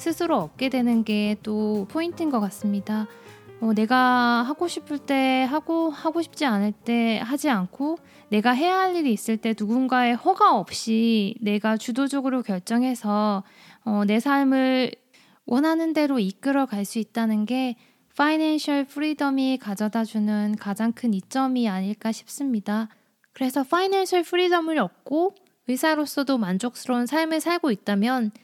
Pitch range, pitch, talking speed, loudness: 215-290 Hz, 250 Hz, 300 characters per minute, -24 LUFS